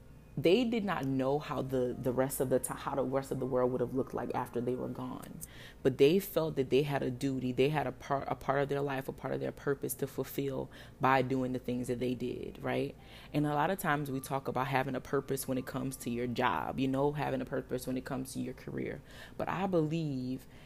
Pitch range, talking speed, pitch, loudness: 125-140 Hz, 255 wpm, 135 Hz, -34 LUFS